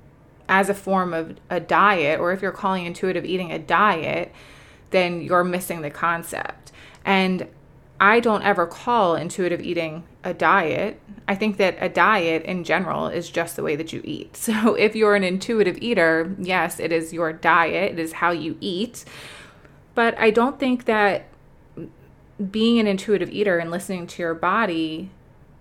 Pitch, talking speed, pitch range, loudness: 185 Hz, 170 wpm, 170-205 Hz, -21 LUFS